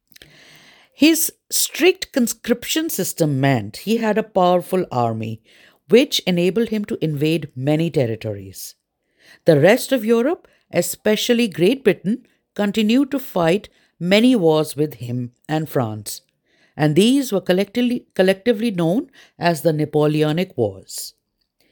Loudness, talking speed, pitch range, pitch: -19 LUFS, 115 wpm, 155-240 Hz, 185 Hz